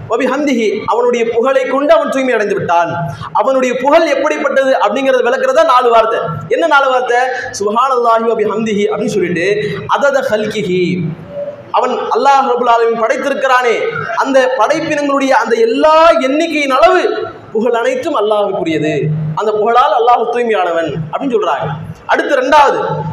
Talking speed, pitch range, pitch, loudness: 125 wpm, 210-285 Hz, 250 Hz, -12 LUFS